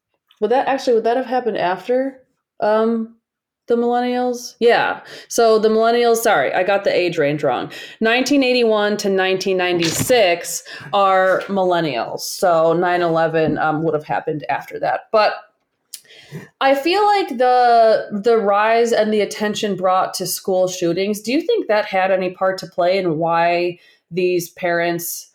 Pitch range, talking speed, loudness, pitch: 175-235 Hz, 145 wpm, -17 LUFS, 200 Hz